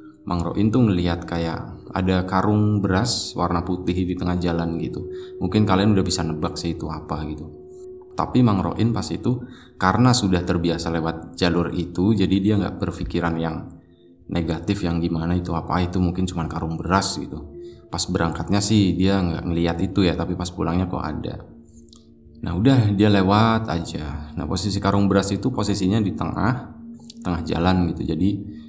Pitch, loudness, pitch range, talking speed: 90 Hz, -22 LUFS, 85-105 Hz, 160 wpm